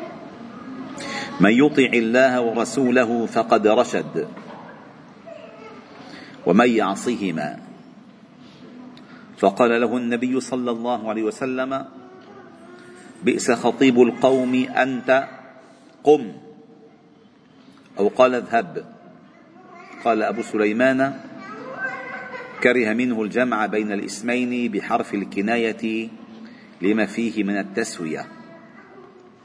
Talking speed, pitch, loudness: 75 wpm, 130 Hz, -21 LUFS